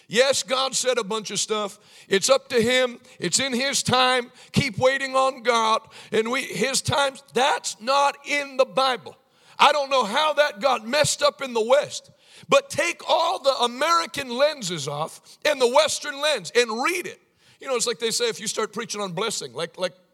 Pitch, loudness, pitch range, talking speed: 265 Hz, -22 LUFS, 225-285 Hz, 200 wpm